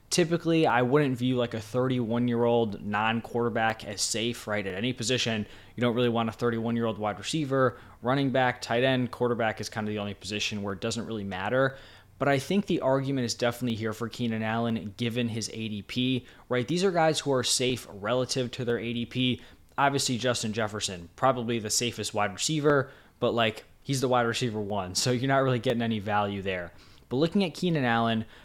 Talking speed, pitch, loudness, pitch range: 205 wpm, 120 Hz, -28 LUFS, 110-130 Hz